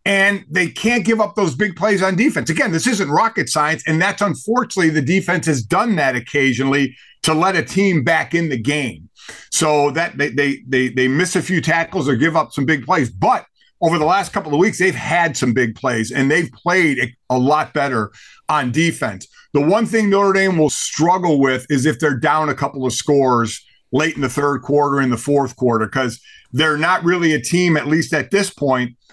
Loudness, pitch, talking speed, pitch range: -17 LUFS, 155 Hz, 215 wpm, 135-180 Hz